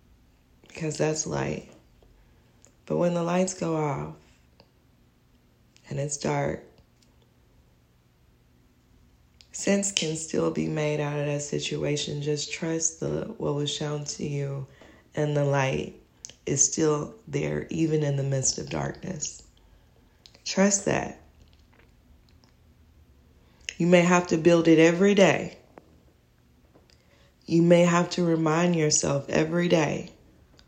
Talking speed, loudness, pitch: 115 wpm, -25 LUFS, 145 Hz